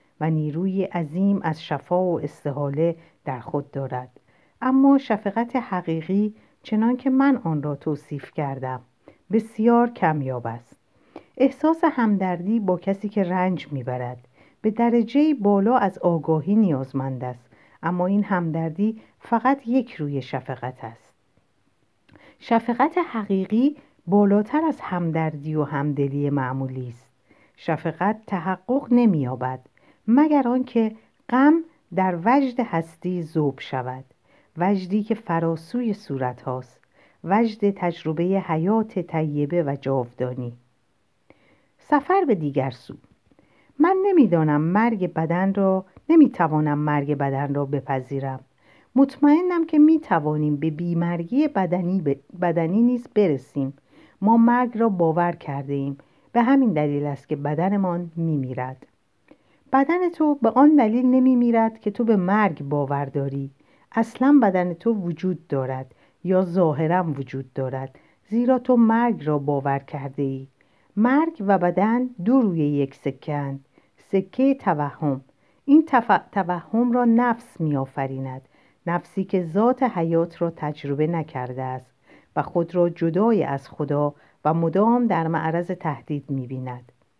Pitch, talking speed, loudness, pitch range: 175 Hz, 125 wpm, -22 LUFS, 145-225 Hz